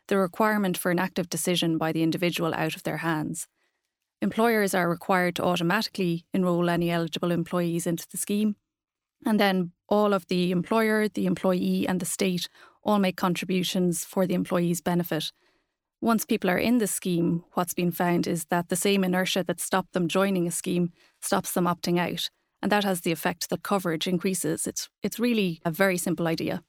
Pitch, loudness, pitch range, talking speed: 180 Hz, -26 LUFS, 175-200 Hz, 185 wpm